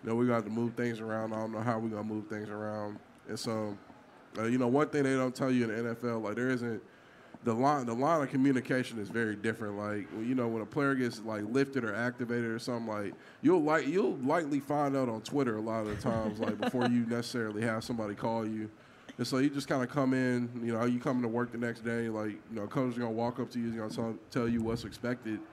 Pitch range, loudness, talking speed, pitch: 110-125 Hz, -33 LUFS, 265 wpm, 115 Hz